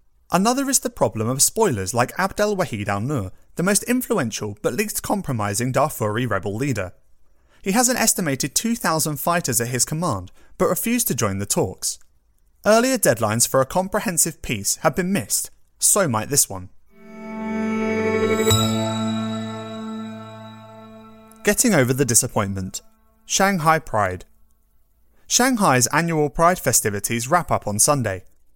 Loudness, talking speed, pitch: -20 LUFS, 130 wpm, 135 Hz